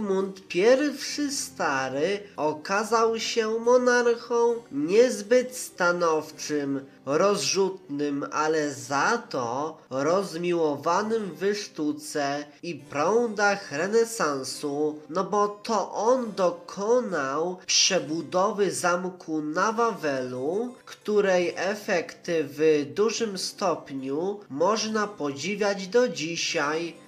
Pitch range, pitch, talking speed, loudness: 155-225 Hz, 190 Hz, 80 wpm, -26 LUFS